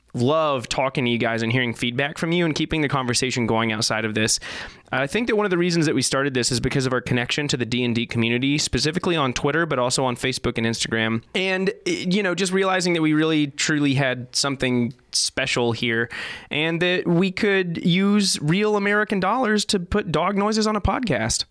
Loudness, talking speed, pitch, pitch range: -21 LUFS, 210 wpm, 145 Hz, 125-180 Hz